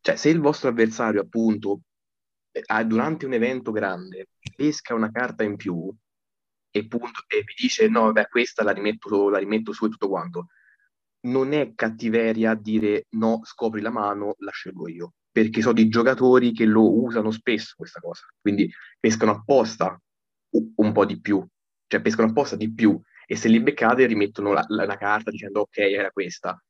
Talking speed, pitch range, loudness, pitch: 175 wpm, 105-120 Hz, -22 LUFS, 110 Hz